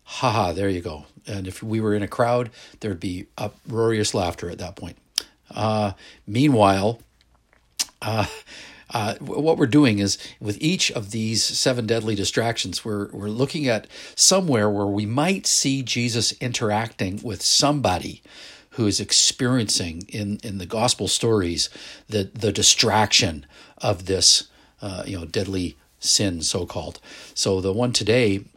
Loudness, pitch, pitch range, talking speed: -21 LUFS, 105 Hz, 95-120 Hz, 145 wpm